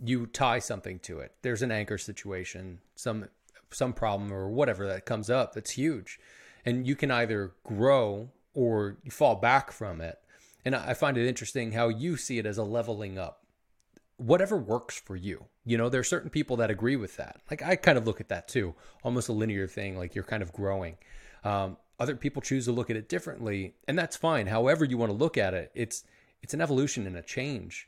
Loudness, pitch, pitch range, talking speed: -30 LUFS, 115 Hz, 100-125 Hz, 215 wpm